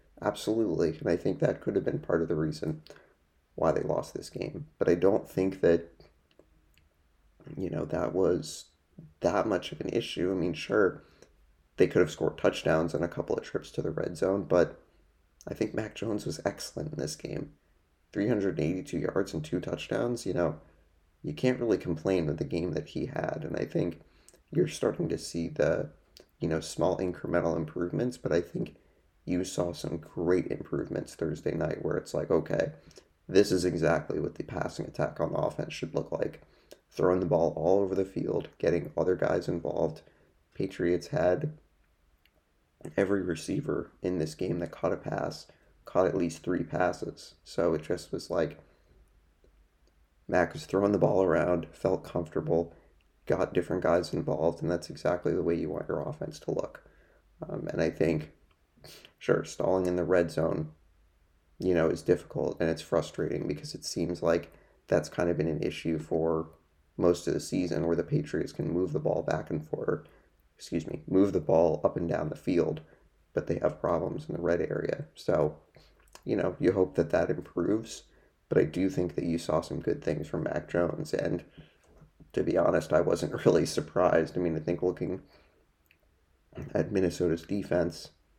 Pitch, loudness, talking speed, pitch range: 85 Hz, -30 LUFS, 180 wpm, 80-90 Hz